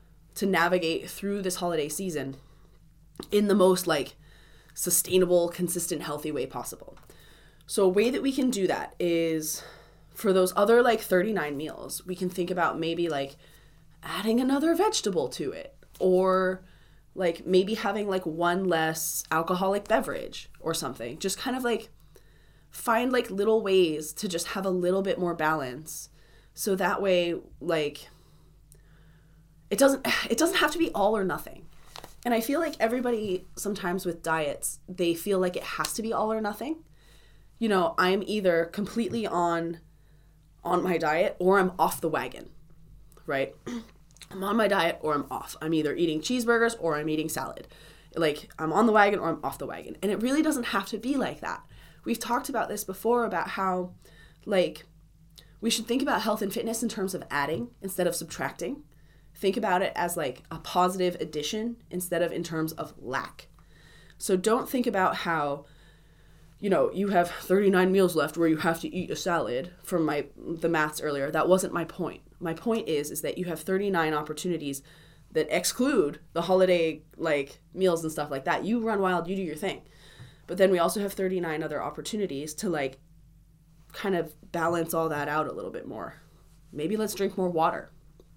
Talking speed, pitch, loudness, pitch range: 180 wpm, 175 Hz, -27 LUFS, 155-200 Hz